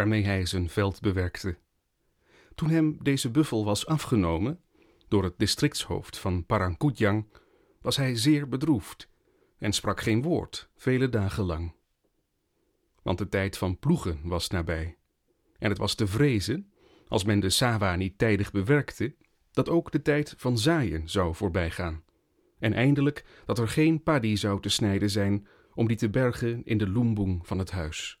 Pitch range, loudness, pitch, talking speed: 95-130 Hz, -27 LUFS, 105 Hz, 155 wpm